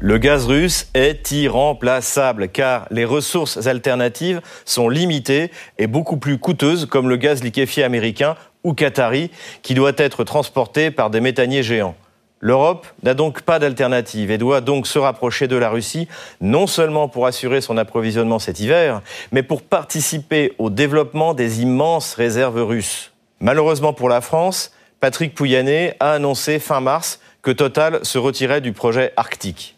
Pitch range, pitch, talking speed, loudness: 120-155 Hz, 135 Hz, 155 wpm, -18 LUFS